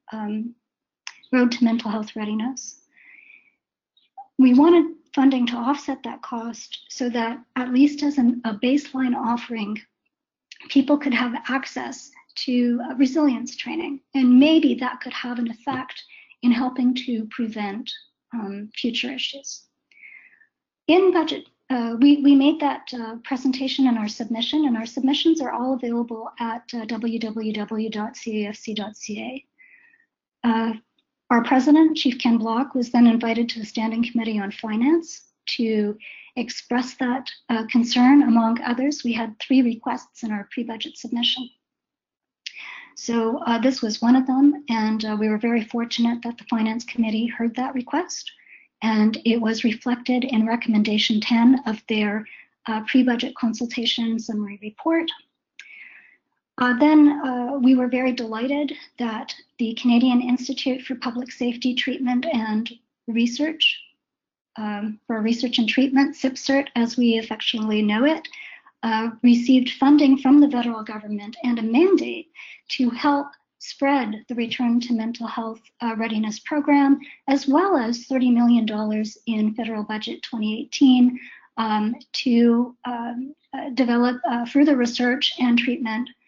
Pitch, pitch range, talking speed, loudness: 245 Hz, 230-275 Hz, 140 wpm, -21 LUFS